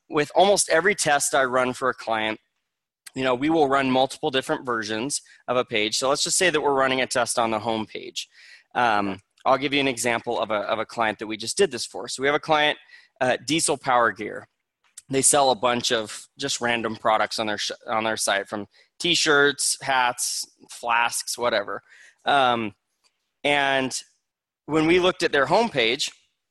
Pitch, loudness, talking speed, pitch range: 125 Hz, -22 LUFS, 195 wpm, 115-145 Hz